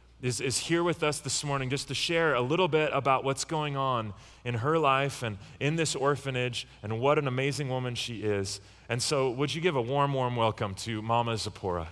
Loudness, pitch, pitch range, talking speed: -29 LUFS, 130 Hz, 115-145 Hz, 215 wpm